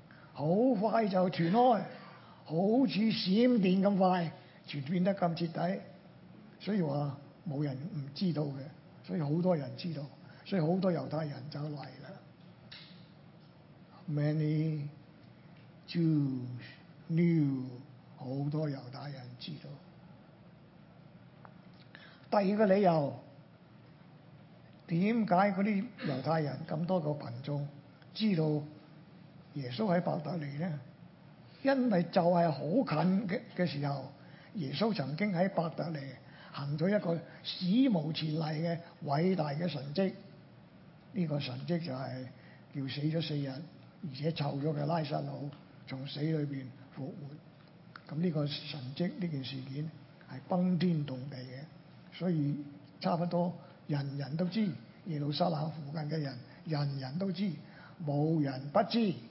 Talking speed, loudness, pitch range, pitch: 190 characters per minute, -33 LUFS, 145-180 Hz, 160 Hz